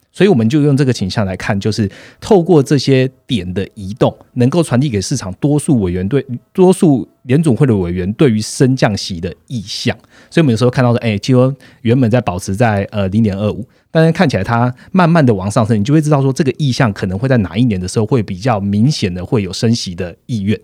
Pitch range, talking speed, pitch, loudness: 100-135 Hz, 345 characters per minute, 120 Hz, -14 LUFS